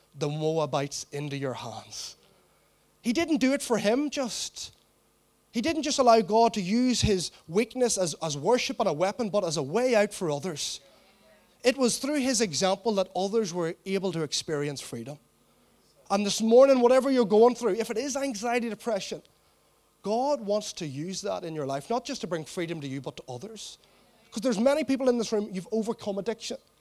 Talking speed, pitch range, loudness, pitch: 190 wpm, 165-245 Hz, -27 LUFS, 210 Hz